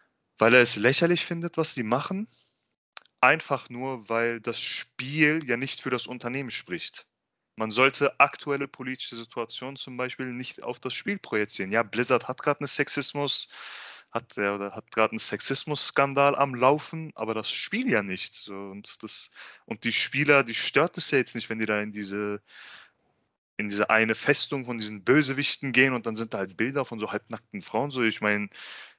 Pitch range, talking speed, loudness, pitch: 110-140 Hz, 180 wpm, -26 LUFS, 125 Hz